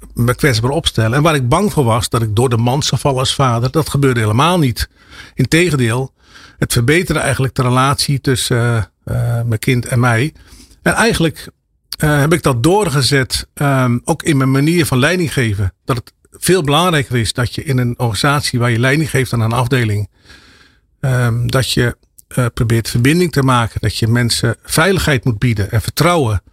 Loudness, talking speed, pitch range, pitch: -14 LUFS, 190 wpm, 120-145 Hz, 130 Hz